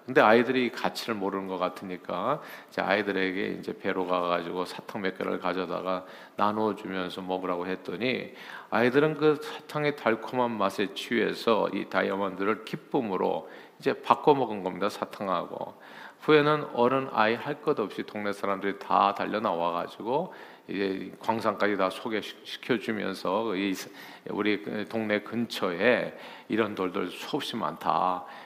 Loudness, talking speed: -28 LUFS, 310 characters per minute